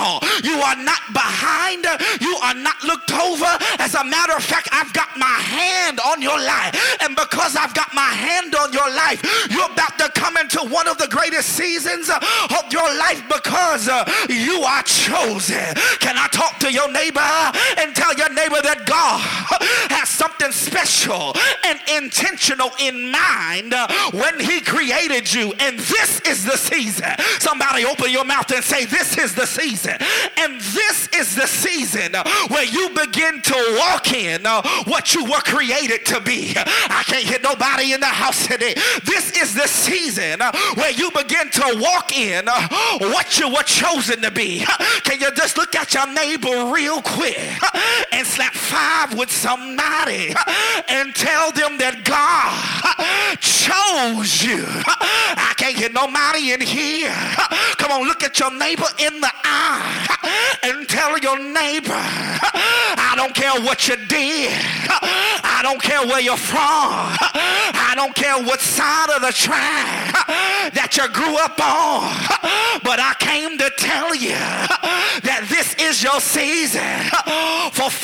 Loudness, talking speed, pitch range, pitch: -16 LUFS, 155 wpm, 265-320 Hz, 295 Hz